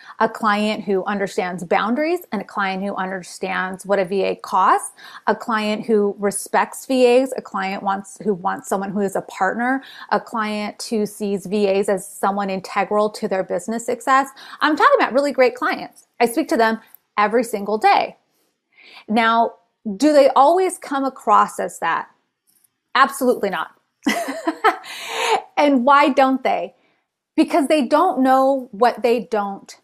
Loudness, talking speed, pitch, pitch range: -19 LUFS, 150 wpm, 220 Hz, 200-265 Hz